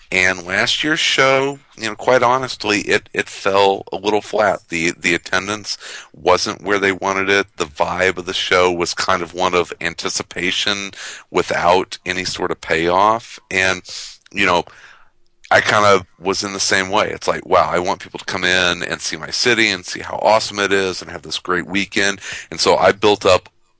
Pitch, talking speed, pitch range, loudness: 95 Hz, 195 wpm, 90-105 Hz, -17 LUFS